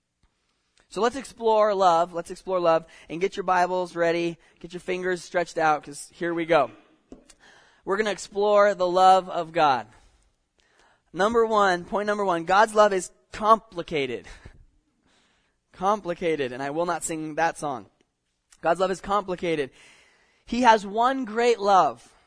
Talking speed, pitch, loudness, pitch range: 145 wpm, 180 Hz, -24 LUFS, 165-205 Hz